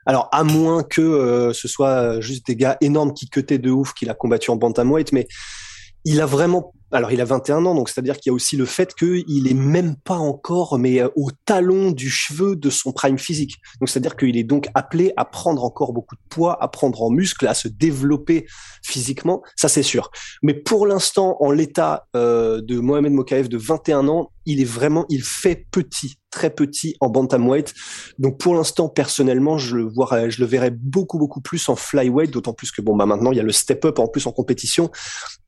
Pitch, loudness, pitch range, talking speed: 140 Hz, -19 LUFS, 125-160 Hz, 215 wpm